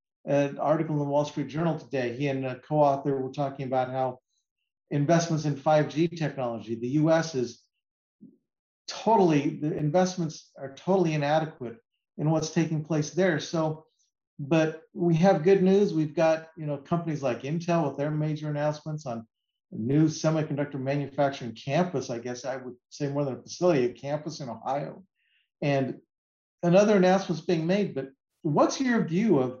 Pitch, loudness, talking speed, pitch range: 150 Hz, -27 LUFS, 160 wpm, 135-165 Hz